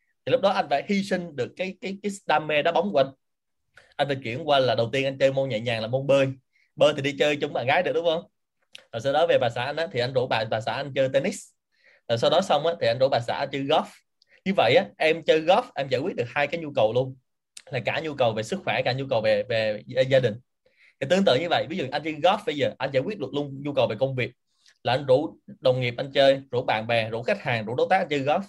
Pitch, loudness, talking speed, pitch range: 140 Hz, -24 LUFS, 300 wpm, 125-165 Hz